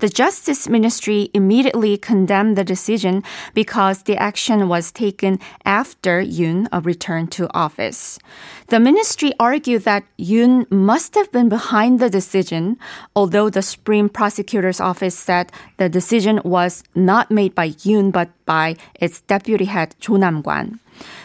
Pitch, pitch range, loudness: 205 Hz, 185-225 Hz, -17 LUFS